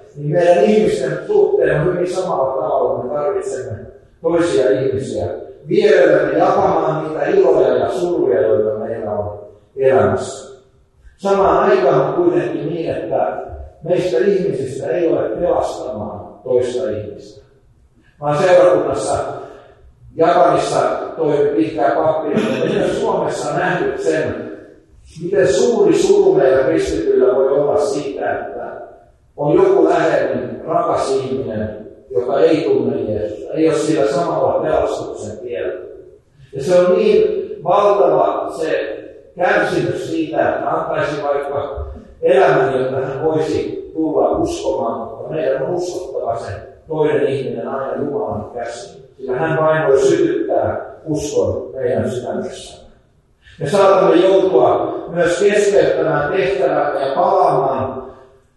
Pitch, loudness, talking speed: 180 Hz, -16 LUFS, 115 wpm